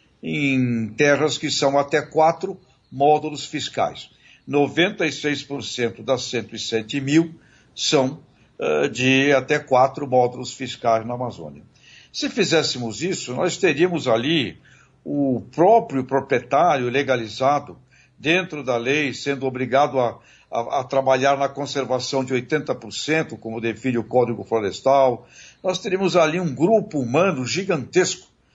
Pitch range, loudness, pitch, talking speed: 125-155 Hz, -21 LUFS, 135 Hz, 120 wpm